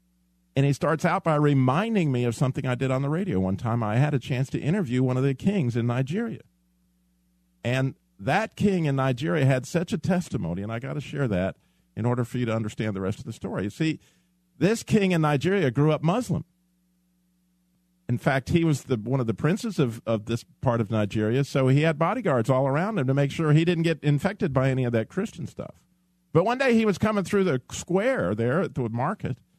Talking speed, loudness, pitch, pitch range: 225 wpm, -25 LUFS, 145 Hz, 120-180 Hz